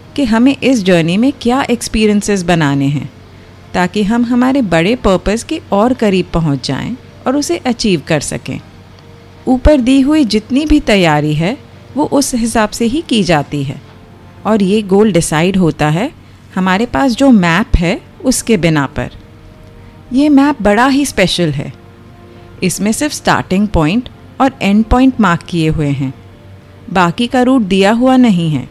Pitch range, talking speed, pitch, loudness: 150-250 Hz, 160 wpm, 200 Hz, -12 LUFS